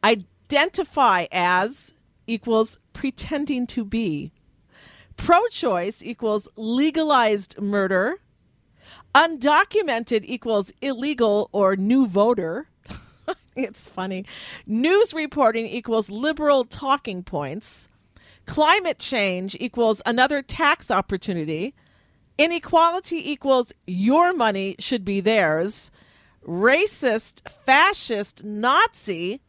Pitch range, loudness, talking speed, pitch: 200-285 Hz, -21 LUFS, 85 wpm, 230 Hz